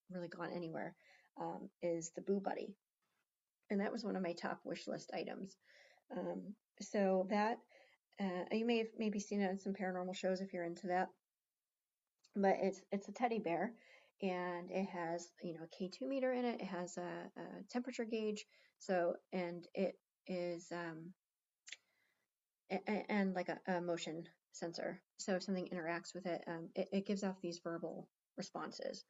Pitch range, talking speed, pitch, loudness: 175-205 Hz, 175 wpm, 185 Hz, -42 LUFS